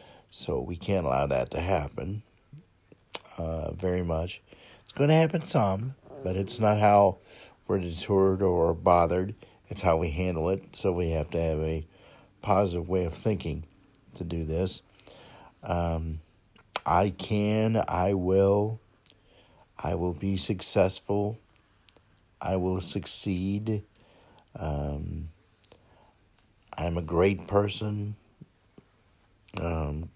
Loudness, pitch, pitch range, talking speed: -28 LUFS, 95 Hz, 85-105 Hz, 115 wpm